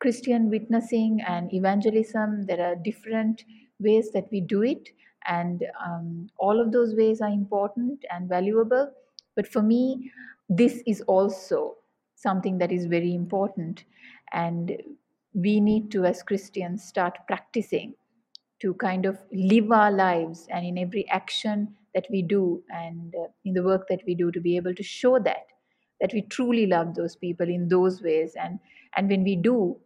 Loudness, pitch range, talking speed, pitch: -26 LUFS, 180-225 Hz, 165 wpm, 200 Hz